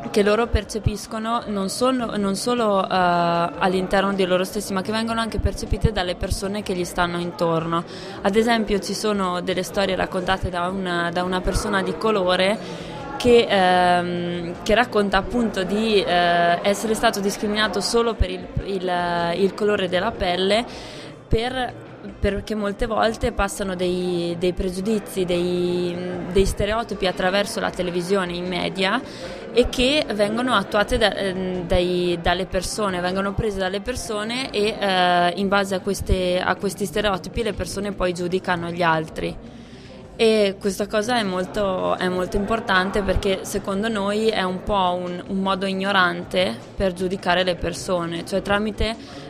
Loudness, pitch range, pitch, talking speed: -22 LUFS, 180-210 Hz, 195 Hz, 150 wpm